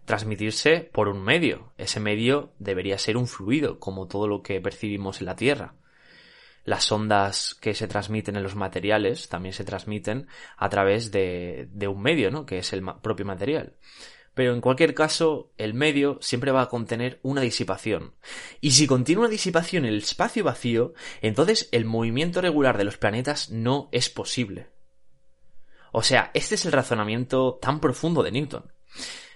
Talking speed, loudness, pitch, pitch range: 170 wpm, -25 LUFS, 115 Hz, 100-140 Hz